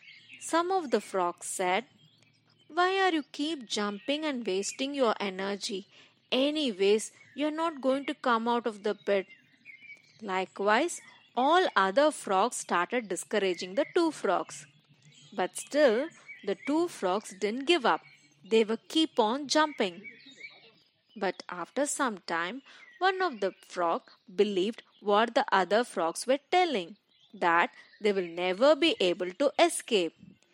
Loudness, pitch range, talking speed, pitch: -29 LUFS, 190-290 Hz, 140 wpm, 225 Hz